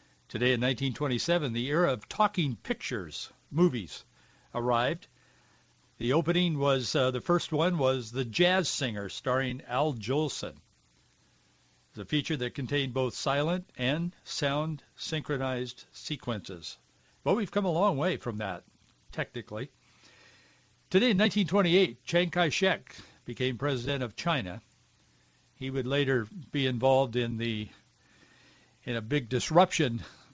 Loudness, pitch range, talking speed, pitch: -30 LUFS, 125-165 Hz, 130 wpm, 135 Hz